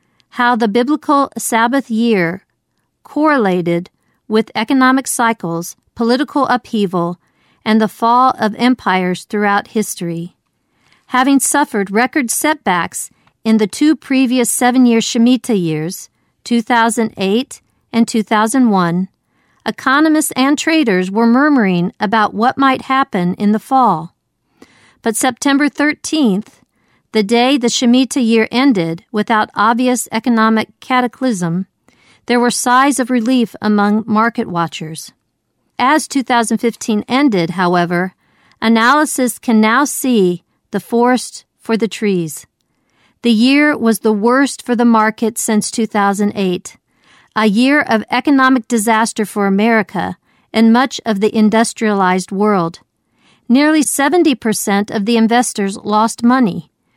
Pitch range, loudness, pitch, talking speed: 205-255 Hz, -14 LUFS, 225 Hz, 115 wpm